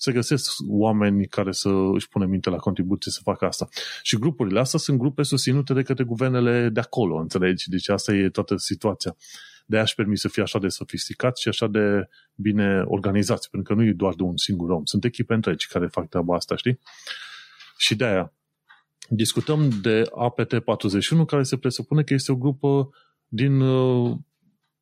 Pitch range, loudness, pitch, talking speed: 100-130 Hz, -23 LUFS, 110 Hz, 180 wpm